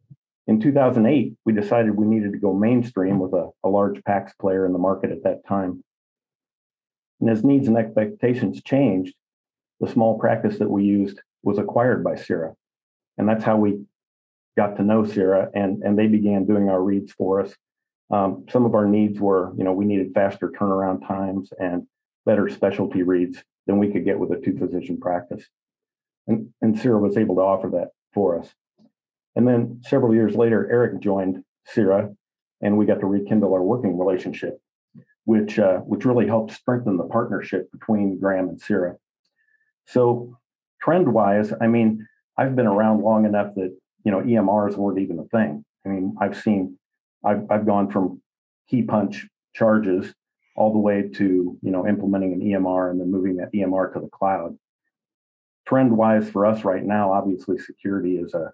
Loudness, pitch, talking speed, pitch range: -21 LUFS, 100 Hz, 175 wpm, 95-110 Hz